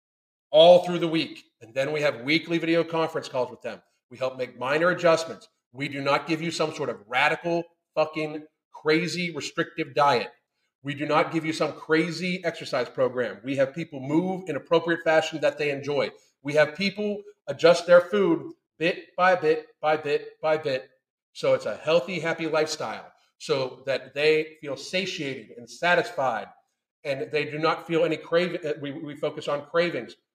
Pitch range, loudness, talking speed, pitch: 150-175 Hz, -25 LUFS, 175 wpm, 160 Hz